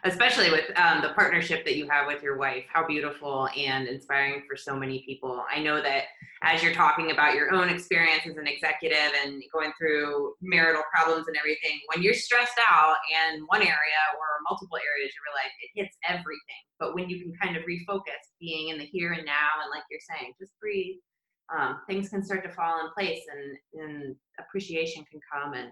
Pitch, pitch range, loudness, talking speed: 155 Hz, 145-180 Hz, -26 LUFS, 205 wpm